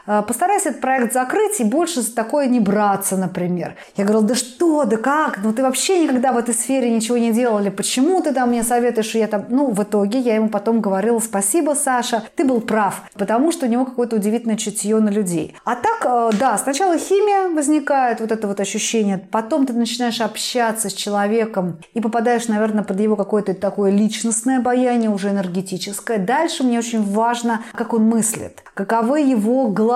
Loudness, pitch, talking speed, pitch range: -18 LUFS, 230 Hz, 190 wpm, 210-255 Hz